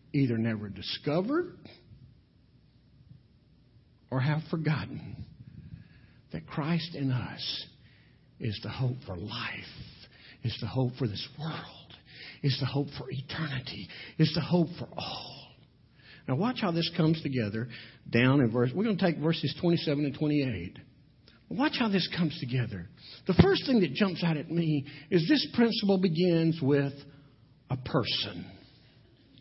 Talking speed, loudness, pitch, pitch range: 140 wpm, -30 LUFS, 140 Hz, 120-165 Hz